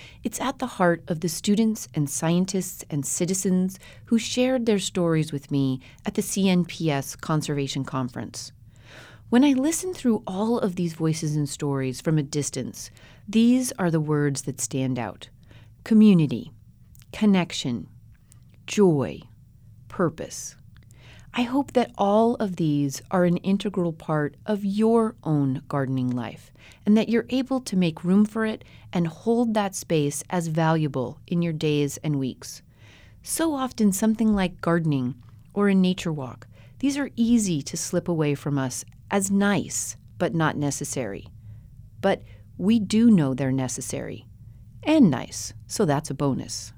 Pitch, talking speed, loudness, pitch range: 160 Hz, 150 wpm, -24 LUFS, 130-205 Hz